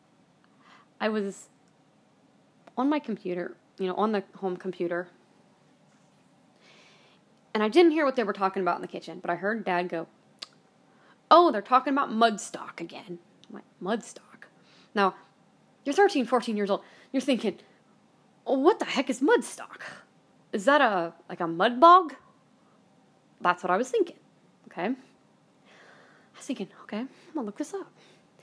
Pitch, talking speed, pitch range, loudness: 215 Hz, 150 wpm, 185-270 Hz, -26 LUFS